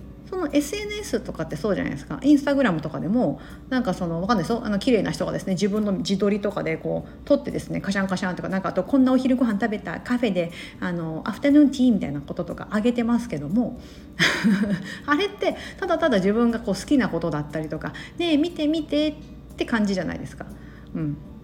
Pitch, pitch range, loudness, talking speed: 210 Hz, 180-270 Hz, -24 LUFS, 465 characters per minute